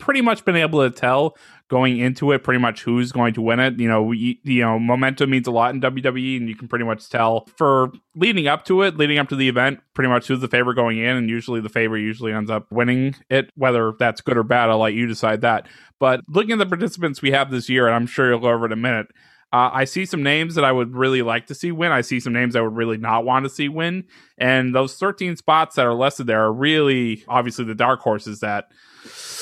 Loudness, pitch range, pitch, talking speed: -19 LUFS, 115-140 Hz, 125 Hz, 260 wpm